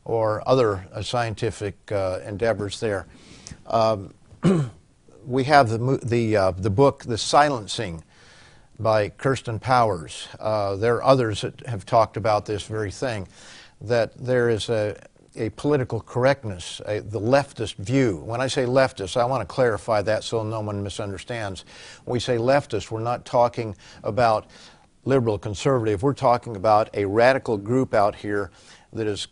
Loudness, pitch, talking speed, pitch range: -23 LUFS, 115 Hz, 155 wpm, 105-125 Hz